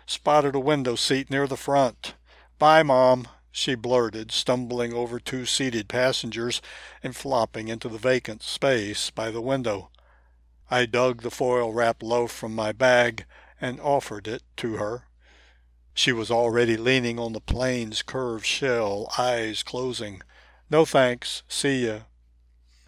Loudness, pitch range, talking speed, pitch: -24 LUFS, 110-130 Hz, 140 wpm, 120 Hz